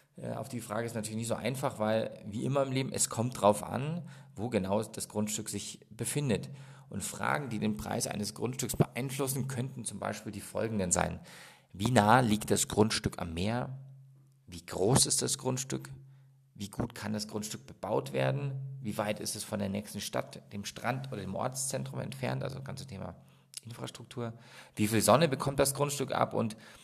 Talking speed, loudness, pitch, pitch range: 185 wpm, -32 LUFS, 115 Hz, 105-135 Hz